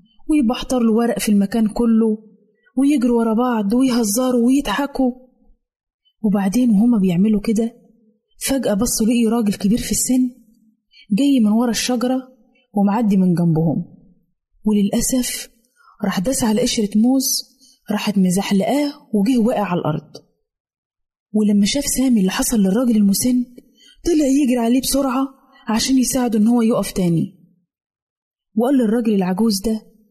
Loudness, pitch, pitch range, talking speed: -18 LUFS, 230 Hz, 210-255 Hz, 120 wpm